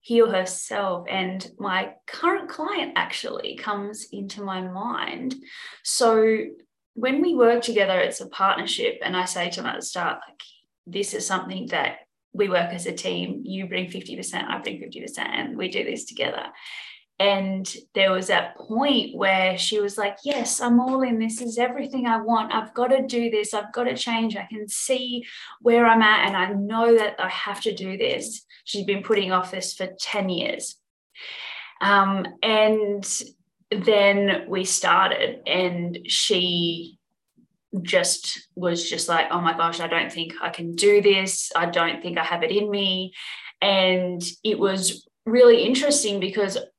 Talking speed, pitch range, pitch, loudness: 175 wpm, 185-235 Hz, 205 Hz, -23 LUFS